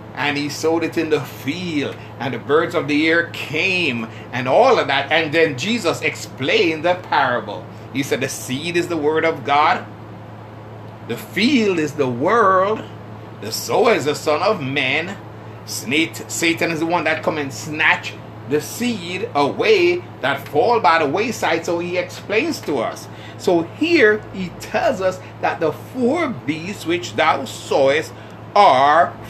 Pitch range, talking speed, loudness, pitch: 110-170 Hz, 160 wpm, -18 LUFS, 150 Hz